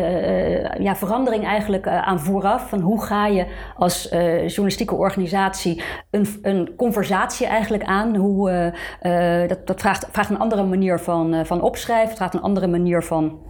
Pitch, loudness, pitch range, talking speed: 195 Hz, -20 LUFS, 175-210 Hz, 175 wpm